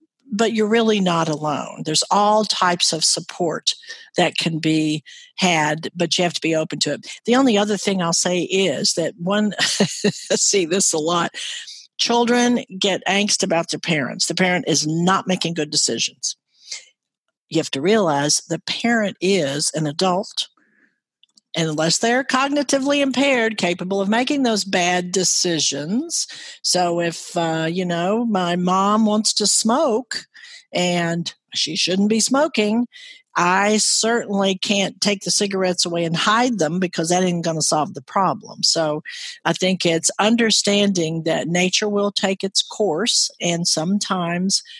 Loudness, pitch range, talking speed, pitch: -19 LUFS, 170-220 Hz, 150 wpm, 190 Hz